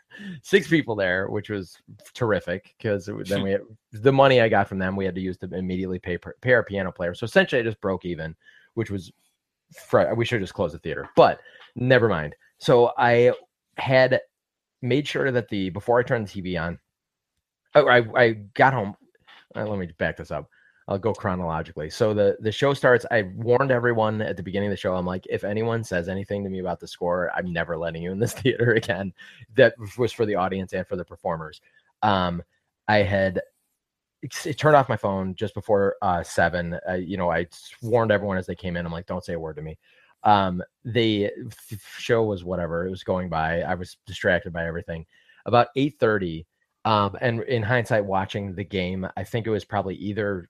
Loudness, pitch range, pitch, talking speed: -24 LUFS, 90-115 Hz, 100 Hz, 205 wpm